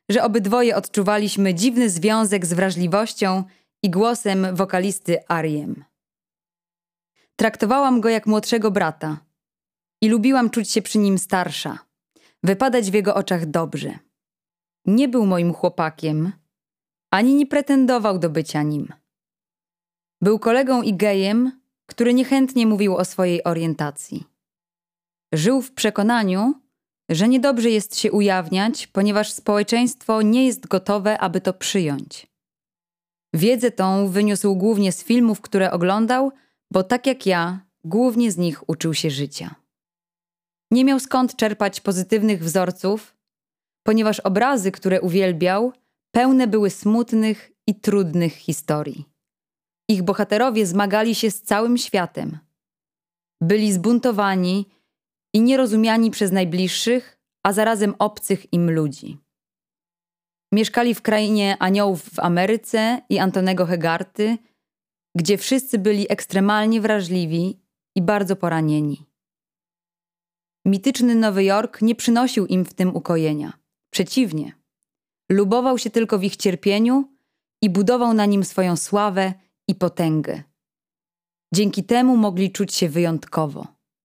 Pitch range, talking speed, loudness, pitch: 175-225 Hz, 115 wpm, -20 LUFS, 200 Hz